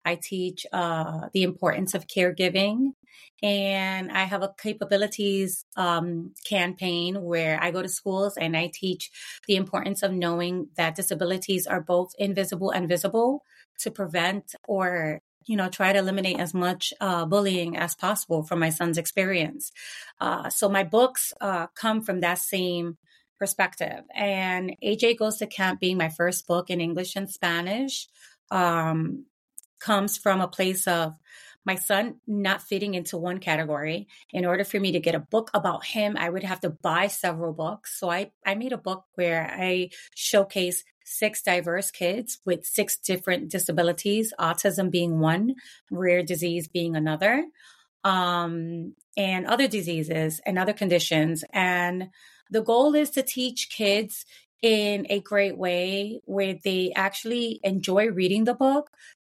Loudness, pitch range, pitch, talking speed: -26 LUFS, 175-205 Hz, 190 Hz, 155 wpm